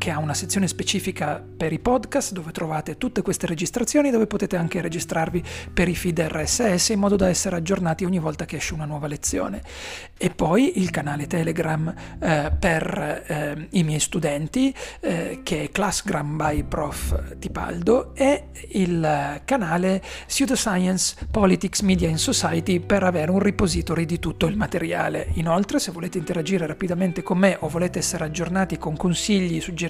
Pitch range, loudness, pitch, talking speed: 165-195 Hz, -23 LUFS, 180 Hz, 165 wpm